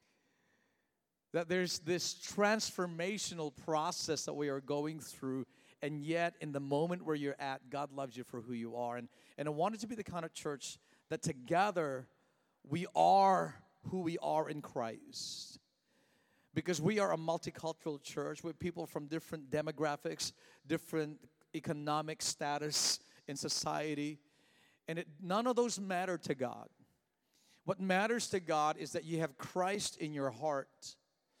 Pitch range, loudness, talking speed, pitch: 145-180 Hz, -38 LUFS, 155 wpm, 160 Hz